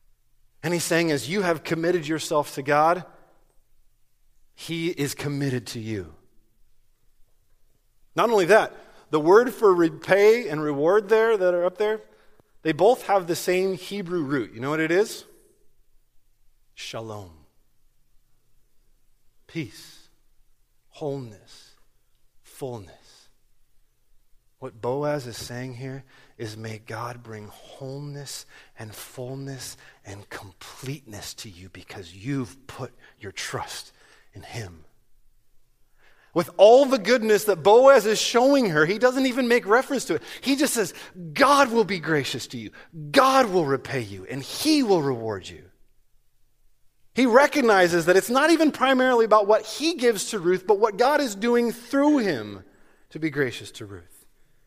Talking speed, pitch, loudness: 140 wpm, 155 Hz, -22 LUFS